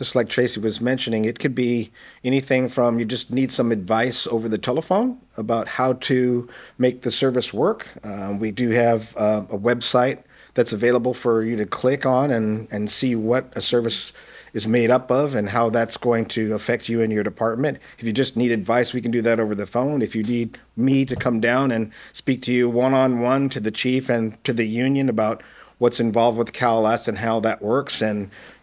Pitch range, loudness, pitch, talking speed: 115-125 Hz, -21 LUFS, 120 Hz, 215 wpm